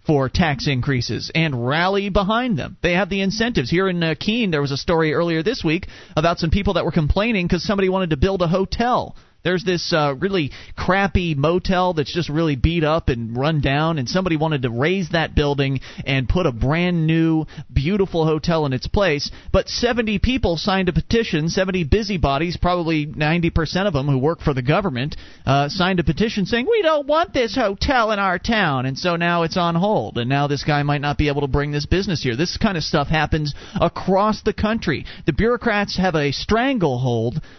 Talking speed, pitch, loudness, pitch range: 205 wpm, 170 Hz, -20 LUFS, 145-190 Hz